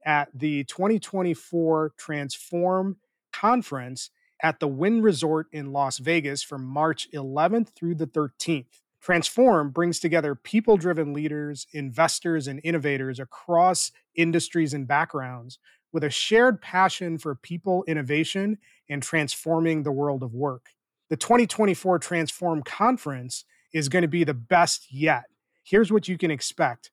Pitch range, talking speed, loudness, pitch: 145-180 Hz, 135 wpm, -25 LUFS, 160 Hz